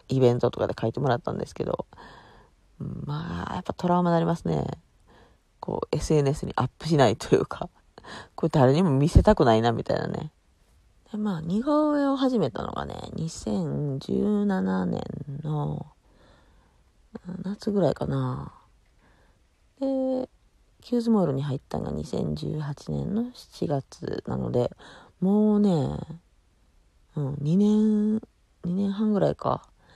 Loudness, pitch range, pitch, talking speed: -26 LUFS, 130-205 Hz, 165 Hz, 240 characters per minute